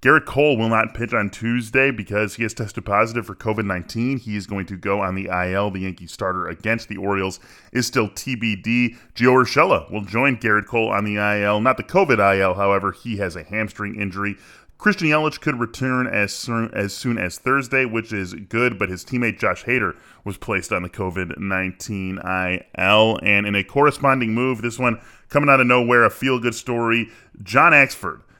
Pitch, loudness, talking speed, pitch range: 110 Hz, -20 LUFS, 195 wpm, 100-125 Hz